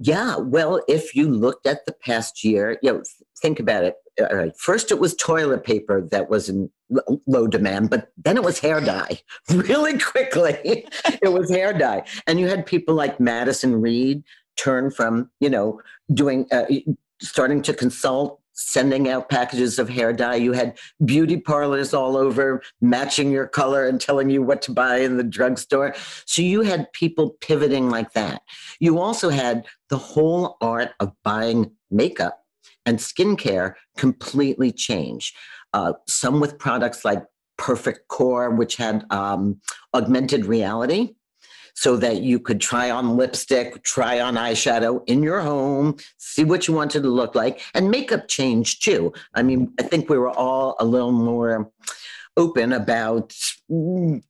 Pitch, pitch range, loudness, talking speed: 135 Hz, 120-155 Hz, -21 LUFS, 160 wpm